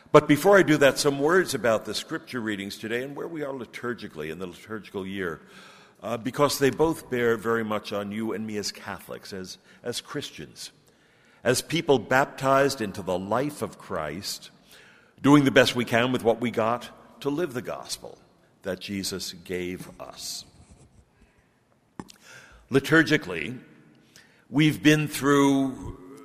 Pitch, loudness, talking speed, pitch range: 120 Hz, -25 LUFS, 150 wpm, 105-145 Hz